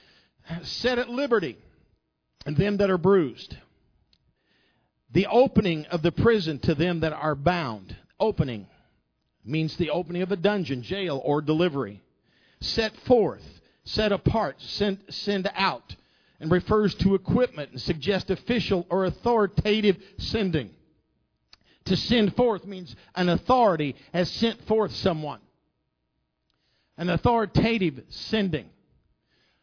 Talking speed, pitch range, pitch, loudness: 115 wpm, 155-205 Hz, 180 Hz, -25 LUFS